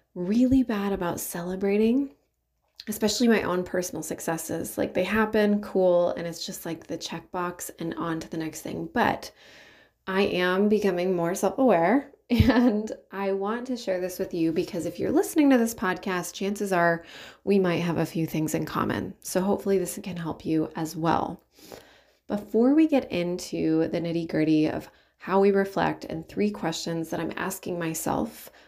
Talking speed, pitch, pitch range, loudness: 175 wpm, 185 Hz, 170-205 Hz, -26 LUFS